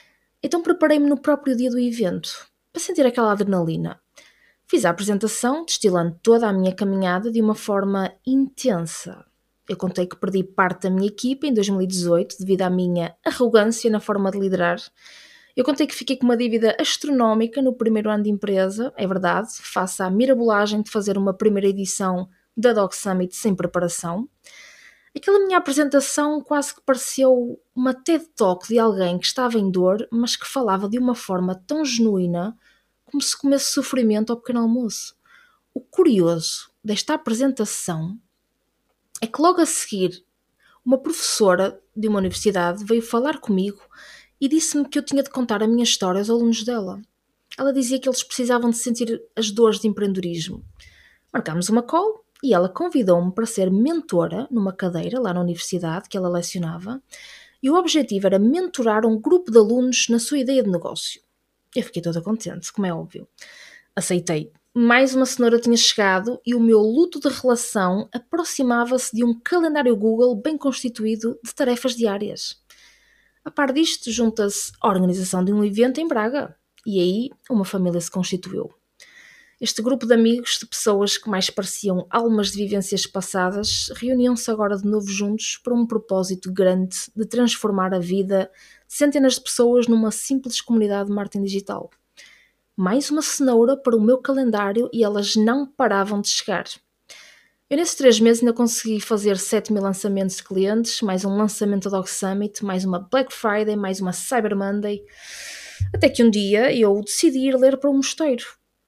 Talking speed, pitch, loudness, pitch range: 165 wpm, 225 Hz, -21 LUFS, 195-260 Hz